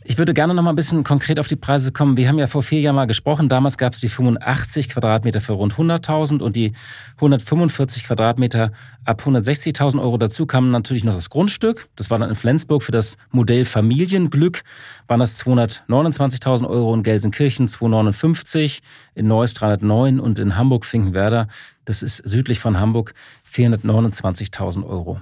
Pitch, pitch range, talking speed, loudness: 125 Hz, 110-145 Hz, 170 wpm, -18 LUFS